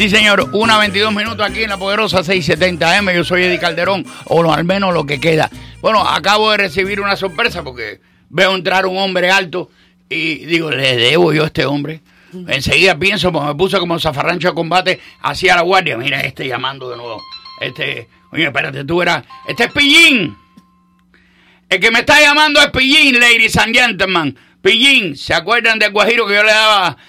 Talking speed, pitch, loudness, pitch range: 185 wpm, 190 Hz, -12 LUFS, 170-215 Hz